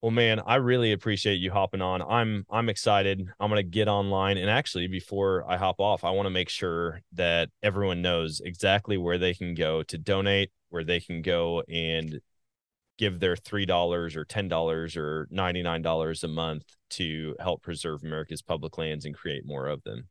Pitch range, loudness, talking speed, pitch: 80-100 Hz, -28 LUFS, 195 wpm, 90 Hz